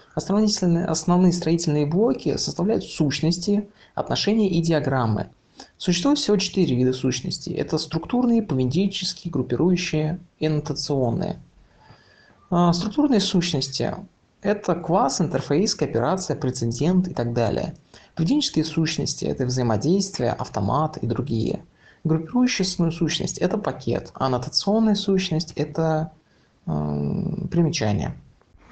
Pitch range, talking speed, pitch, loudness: 135-190 Hz, 95 wpm, 160 Hz, -23 LUFS